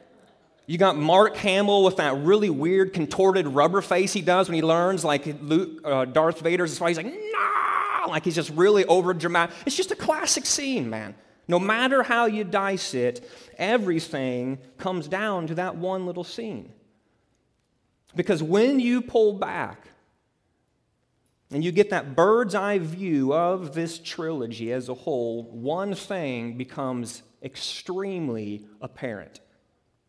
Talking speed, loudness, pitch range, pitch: 150 wpm, -24 LUFS, 145-200 Hz, 175 Hz